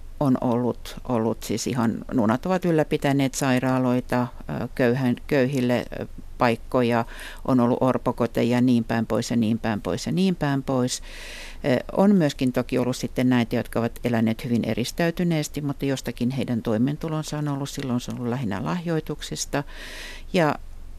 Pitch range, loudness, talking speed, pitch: 120-140 Hz, -24 LUFS, 145 wpm, 125 Hz